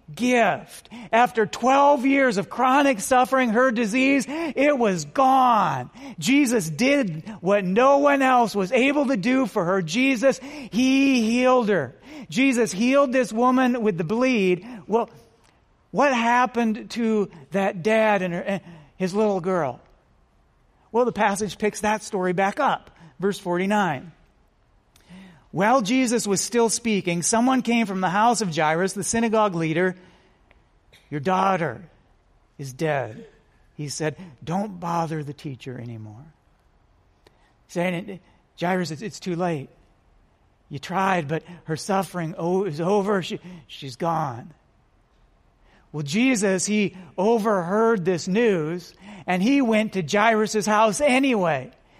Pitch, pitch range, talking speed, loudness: 205 Hz, 175-240 Hz, 130 wpm, -22 LUFS